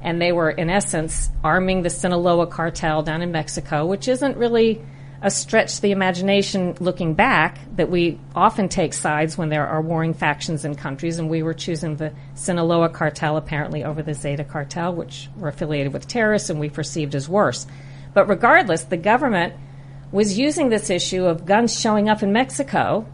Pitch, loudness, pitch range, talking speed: 165 Hz, -20 LUFS, 150-195 Hz, 180 wpm